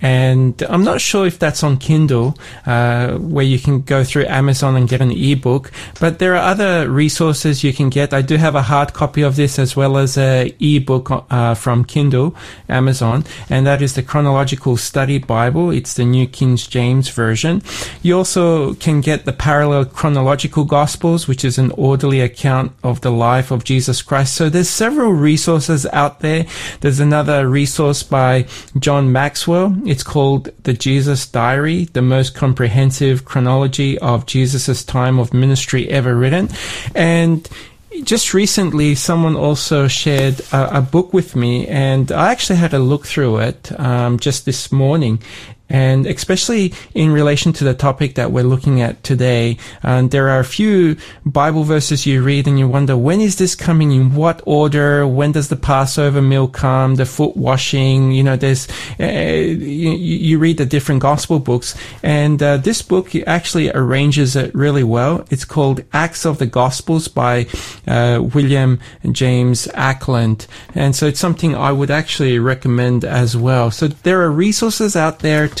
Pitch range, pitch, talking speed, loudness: 130-155 Hz, 140 Hz, 170 wpm, -15 LUFS